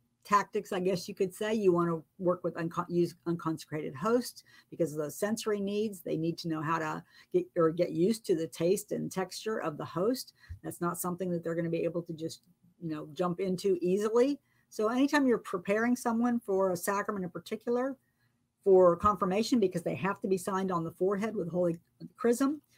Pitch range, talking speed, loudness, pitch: 170-210 Hz, 205 wpm, -31 LUFS, 185 Hz